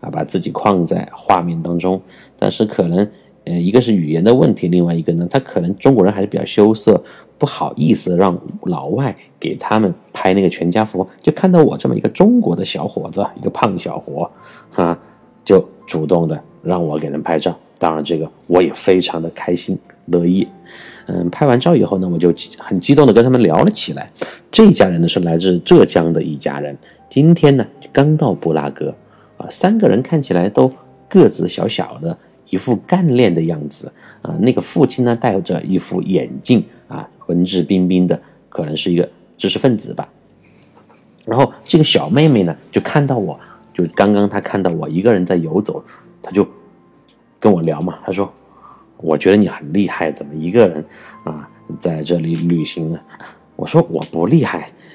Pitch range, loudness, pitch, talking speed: 85-120 Hz, -15 LUFS, 90 Hz, 270 characters per minute